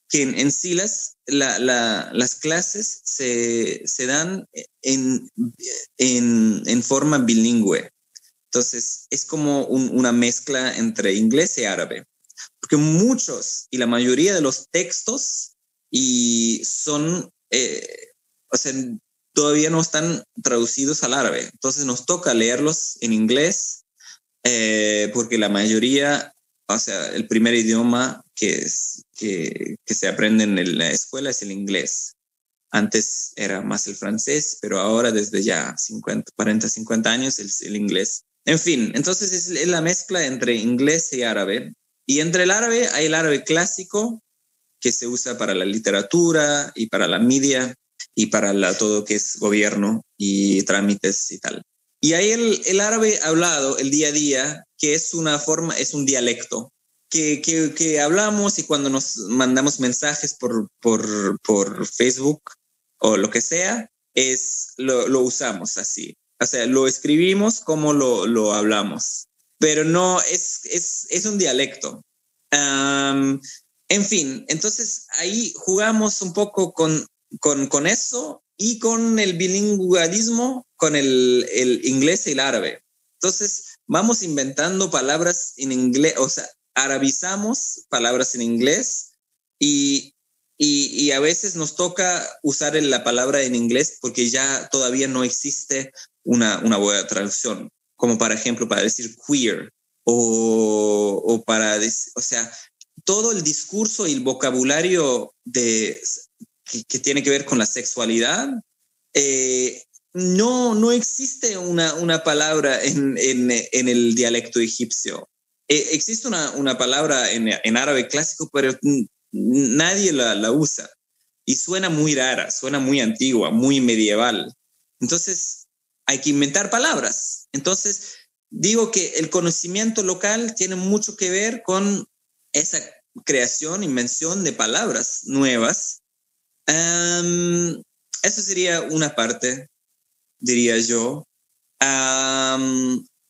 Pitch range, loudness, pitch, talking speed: 120-185 Hz, -20 LUFS, 145 Hz, 140 wpm